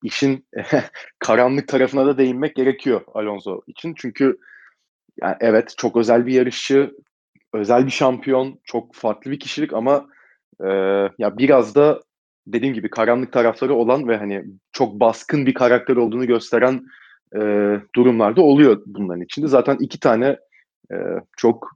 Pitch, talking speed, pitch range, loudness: 125 Hz, 140 wpm, 115-135 Hz, -18 LUFS